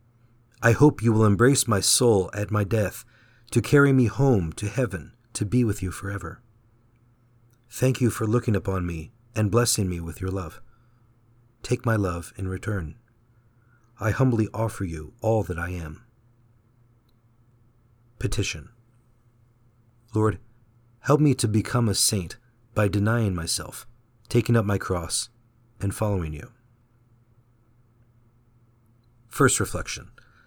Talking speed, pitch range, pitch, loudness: 130 wpm, 105-120 Hz, 115 Hz, -24 LUFS